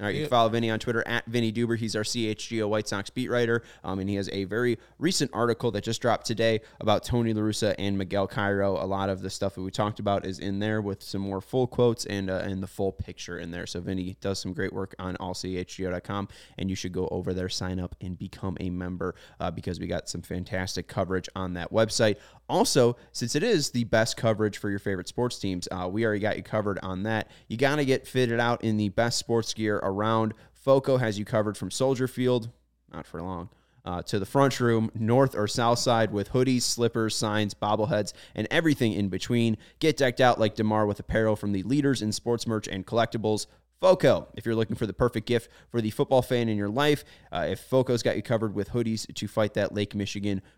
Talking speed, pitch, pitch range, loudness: 230 wpm, 110 Hz, 95-120 Hz, -27 LUFS